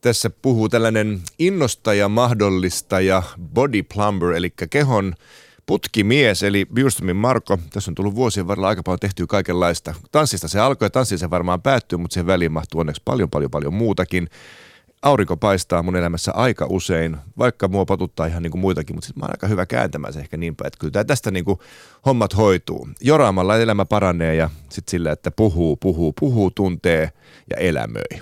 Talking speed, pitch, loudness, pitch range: 170 wpm, 95 Hz, -19 LUFS, 85-110 Hz